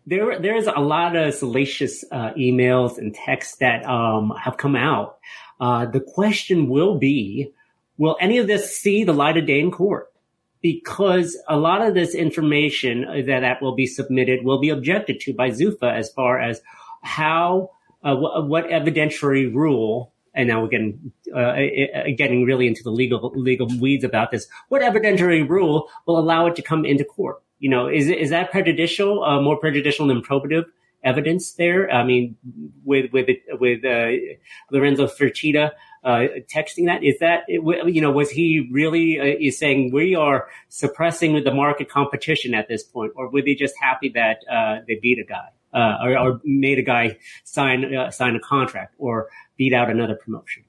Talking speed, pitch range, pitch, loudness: 180 wpm, 125-165 Hz, 140 Hz, -20 LUFS